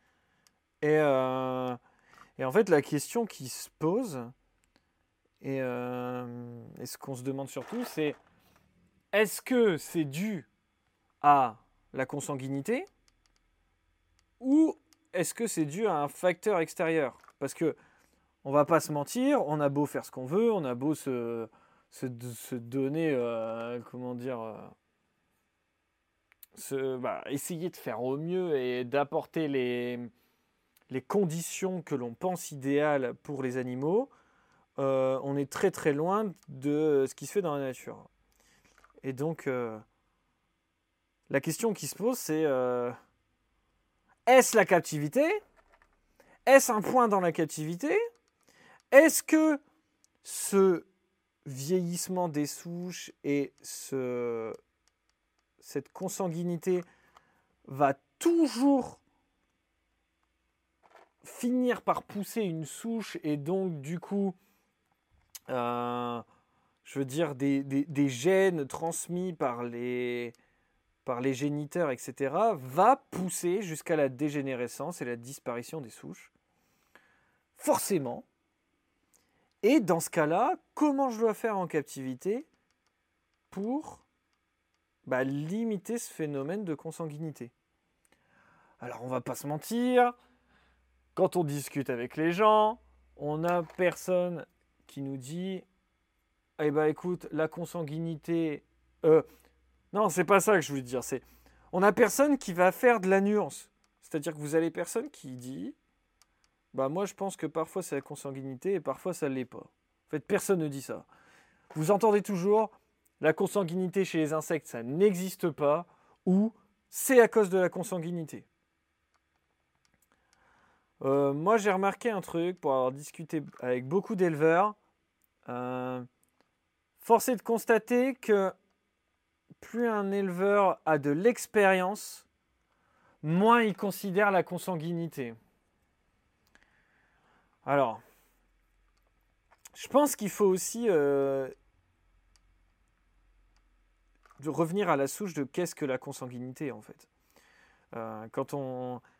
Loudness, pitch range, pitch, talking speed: -30 LUFS, 130-195 Hz, 155 Hz, 125 wpm